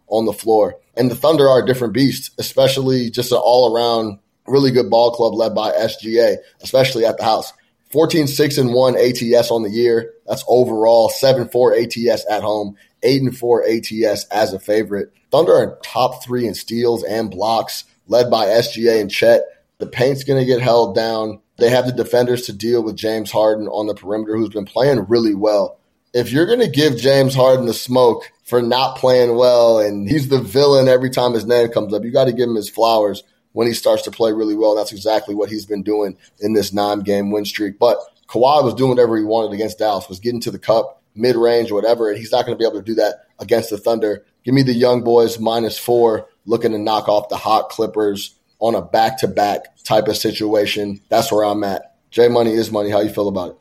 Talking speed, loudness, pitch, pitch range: 215 wpm, -16 LUFS, 115 Hz, 105-125 Hz